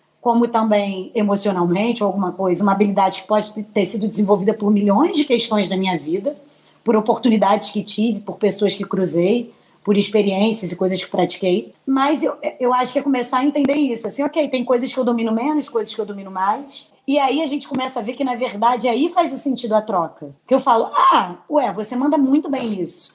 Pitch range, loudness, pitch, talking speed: 200-265 Hz, -18 LUFS, 225 Hz, 215 wpm